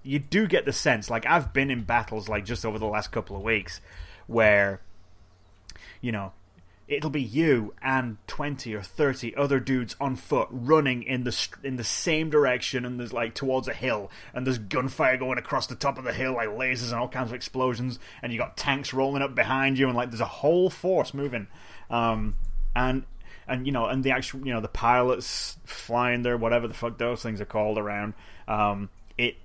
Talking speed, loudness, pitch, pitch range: 205 wpm, -27 LUFS, 120 Hz, 105-130 Hz